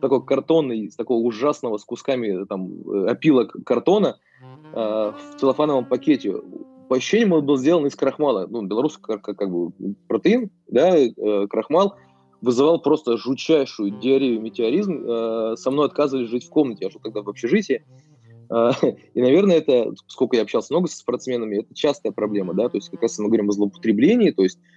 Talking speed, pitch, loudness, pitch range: 170 wpm, 125 Hz, -21 LUFS, 110-145 Hz